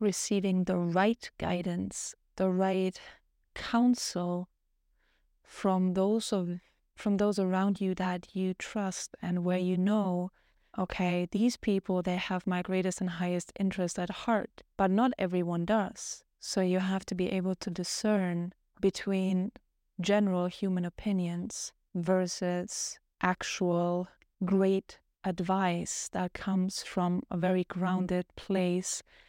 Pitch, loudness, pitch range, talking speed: 185 Hz, -31 LUFS, 180-195 Hz, 125 wpm